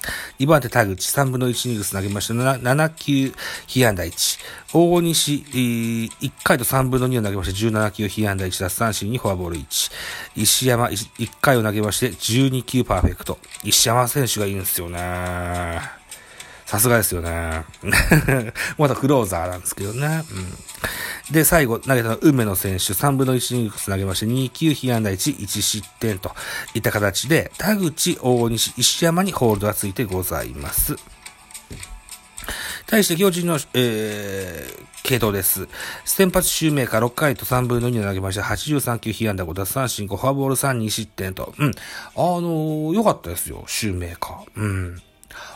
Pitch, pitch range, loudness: 115 Hz, 100-135 Hz, -20 LUFS